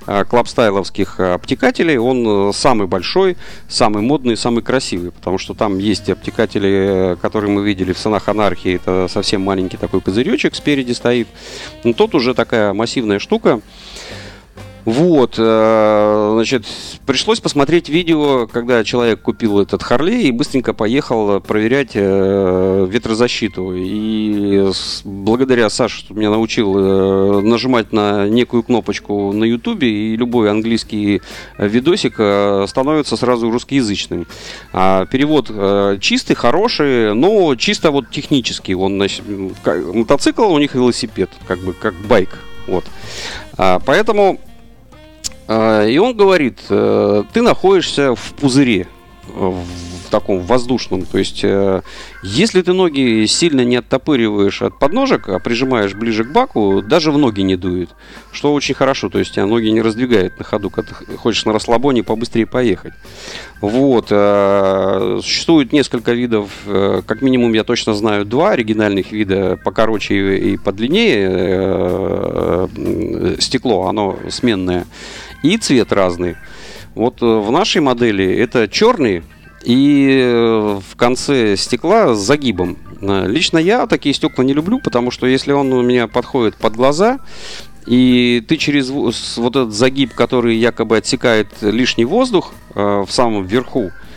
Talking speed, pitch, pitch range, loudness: 125 wpm, 110 Hz, 100-125 Hz, -15 LUFS